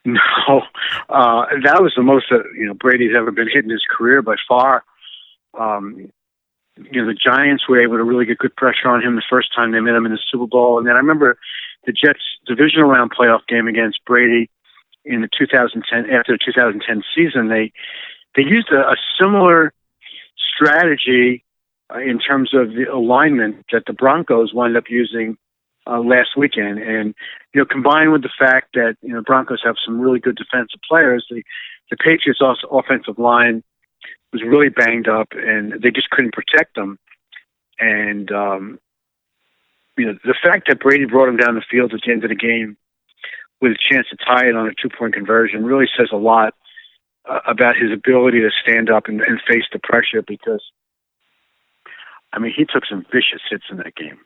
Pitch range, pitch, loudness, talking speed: 115-130 Hz, 120 Hz, -15 LUFS, 190 wpm